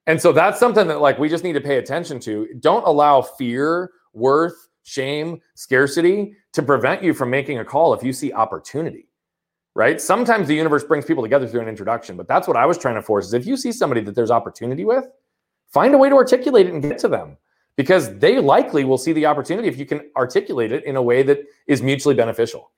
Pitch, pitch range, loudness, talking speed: 145 Hz, 130-180 Hz, -18 LUFS, 230 wpm